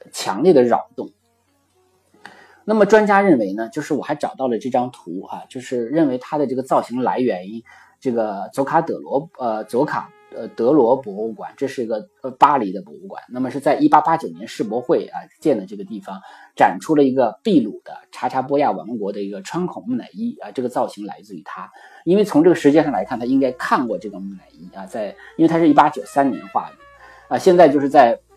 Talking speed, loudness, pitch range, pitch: 320 characters per minute, -18 LUFS, 120-200 Hz, 145 Hz